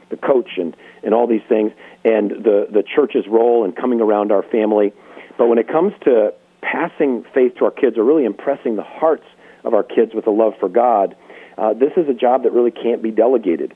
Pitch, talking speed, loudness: 125 Hz, 220 wpm, -17 LUFS